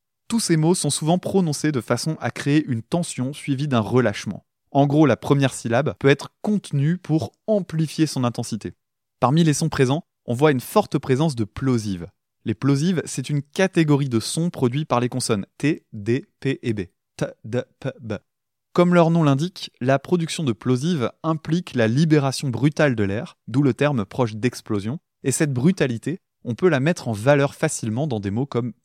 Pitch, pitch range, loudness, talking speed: 140 Hz, 120-160 Hz, -22 LUFS, 190 wpm